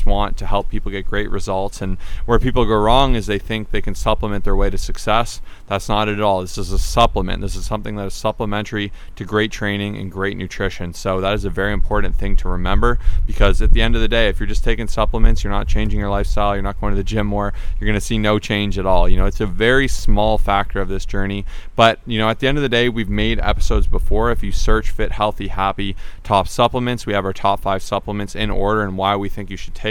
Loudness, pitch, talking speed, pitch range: -20 LUFS, 100 Hz, 260 wpm, 95-110 Hz